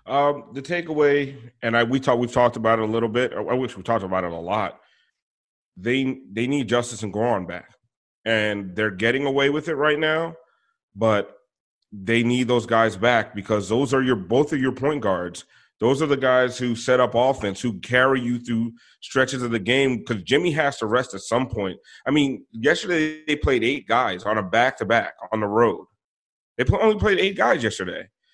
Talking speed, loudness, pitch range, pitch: 205 wpm, -22 LUFS, 115-140 Hz, 120 Hz